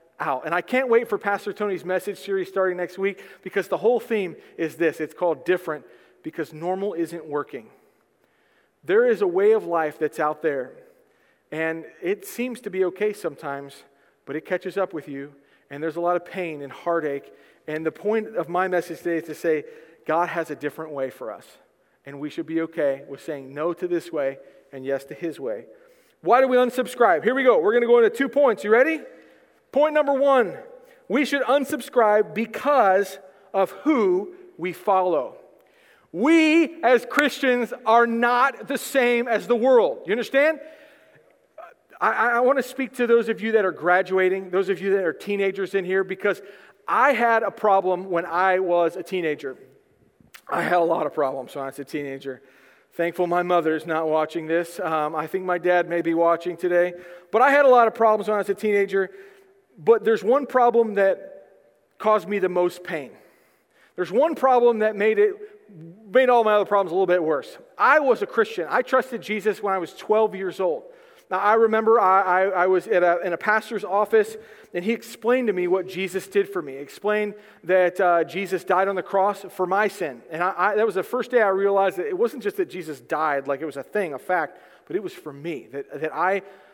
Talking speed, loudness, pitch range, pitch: 210 wpm, -22 LUFS, 170-245 Hz, 195 Hz